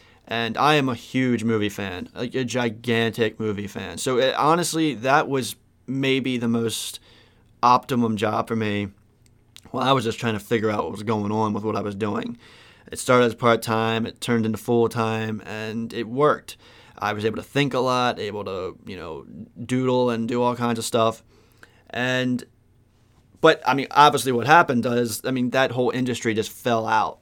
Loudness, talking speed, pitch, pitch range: -22 LUFS, 195 wpm, 115 Hz, 110-125 Hz